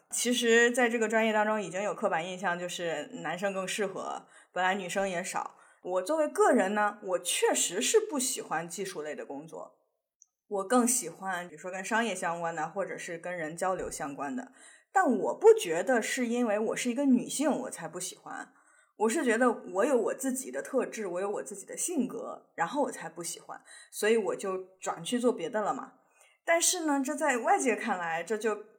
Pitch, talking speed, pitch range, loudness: 215 Hz, 290 characters per minute, 185-250 Hz, -30 LUFS